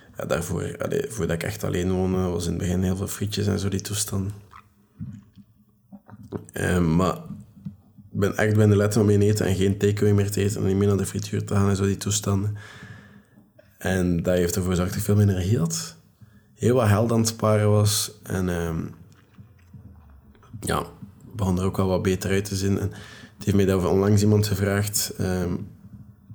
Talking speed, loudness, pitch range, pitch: 200 wpm, -23 LUFS, 95-105 Hz, 100 Hz